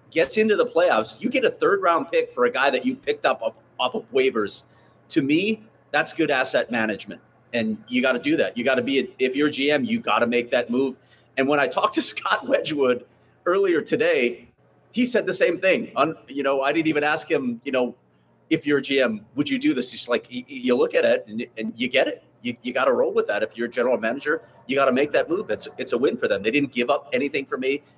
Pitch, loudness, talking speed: 210 Hz, -23 LUFS, 255 wpm